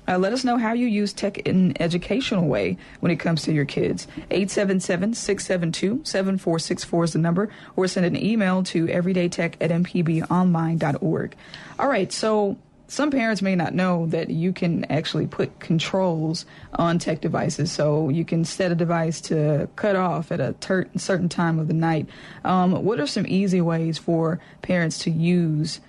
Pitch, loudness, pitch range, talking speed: 175 Hz, -23 LUFS, 165-190 Hz, 175 wpm